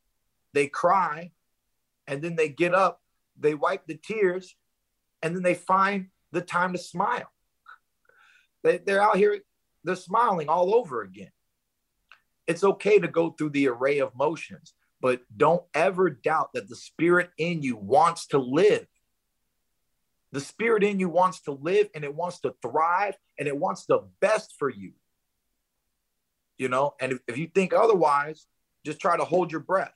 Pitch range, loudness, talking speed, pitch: 150-190 Hz, -25 LUFS, 165 wpm, 175 Hz